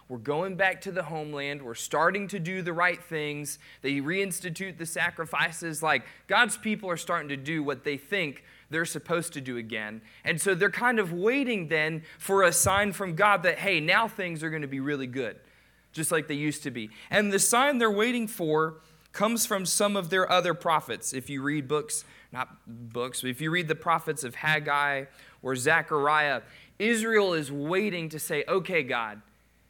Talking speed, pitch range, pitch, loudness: 195 wpm, 145-190 Hz, 165 Hz, -27 LUFS